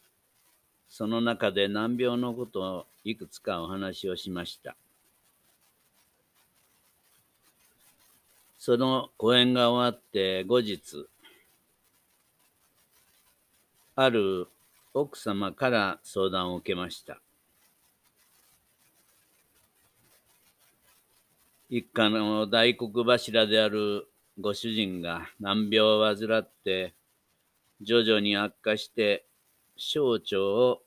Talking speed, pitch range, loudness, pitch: 145 characters per minute, 100-120 Hz, -27 LUFS, 110 Hz